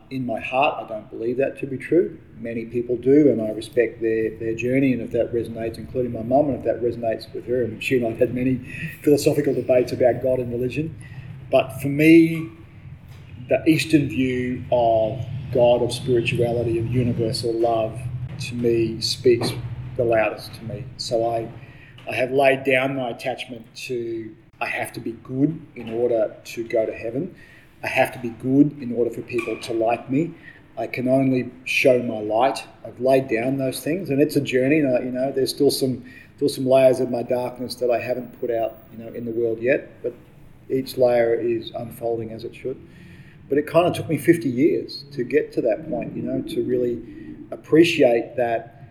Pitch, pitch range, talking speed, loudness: 125 Hz, 115-135 Hz, 200 wpm, -22 LUFS